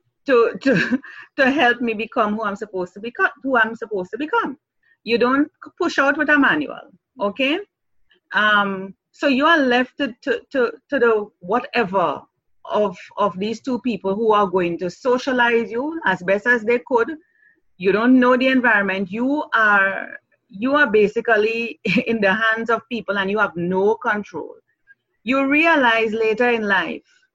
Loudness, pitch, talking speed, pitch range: -19 LUFS, 235 Hz, 165 wpm, 210-275 Hz